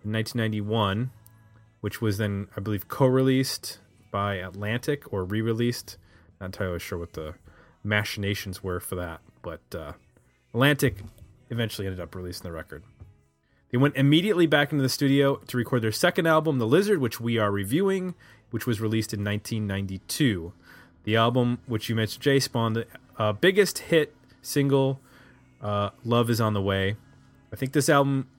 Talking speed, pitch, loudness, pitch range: 165 wpm, 110 Hz, -26 LUFS, 100-130 Hz